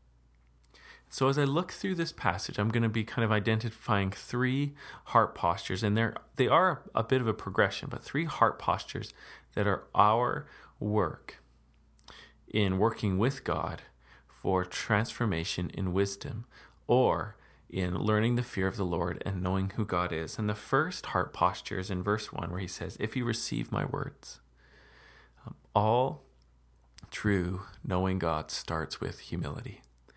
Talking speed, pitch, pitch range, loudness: 155 wpm, 100 Hz, 85-115 Hz, -31 LUFS